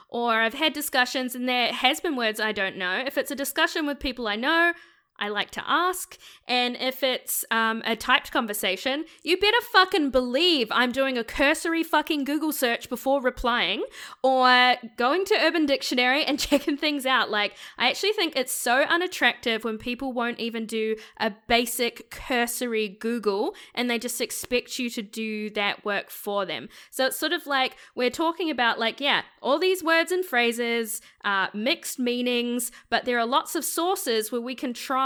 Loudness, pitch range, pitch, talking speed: -24 LUFS, 230-290 Hz, 250 Hz, 185 wpm